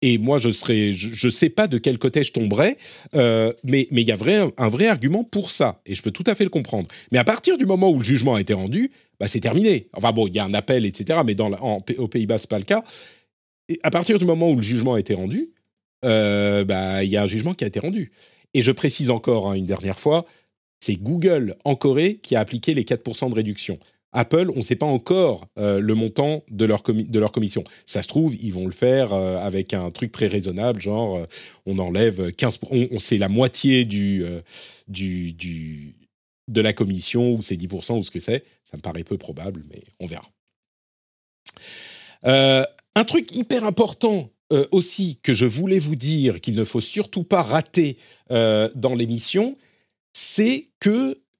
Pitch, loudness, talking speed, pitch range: 120 Hz, -21 LUFS, 220 wpm, 105-155 Hz